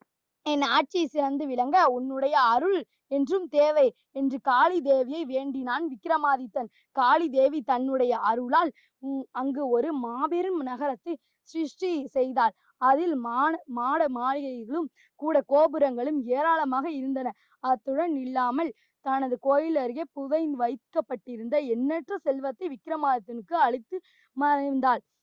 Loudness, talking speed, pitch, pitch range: -27 LUFS, 100 wpm, 275 Hz, 255-315 Hz